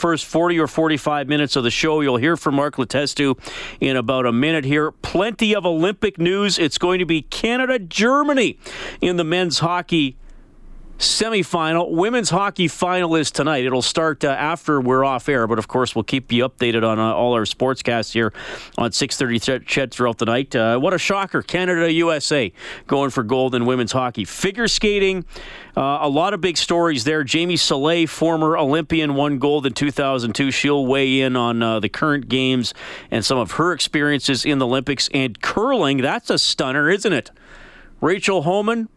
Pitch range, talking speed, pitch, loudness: 130-170 Hz, 185 wpm, 145 Hz, -19 LUFS